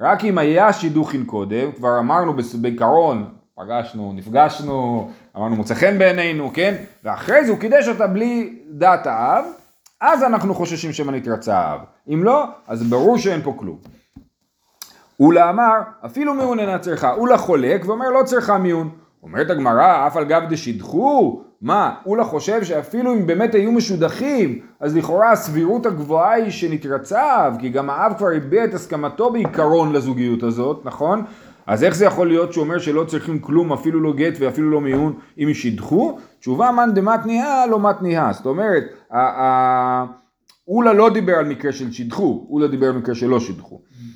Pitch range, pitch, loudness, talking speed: 130-210 Hz, 160 Hz, -18 LUFS, 165 wpm